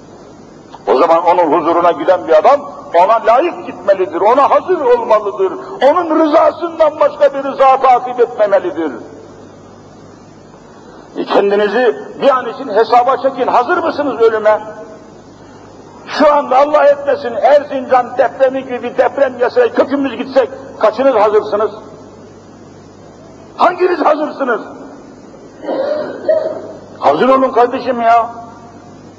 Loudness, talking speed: -12 LUFS, 100 wpm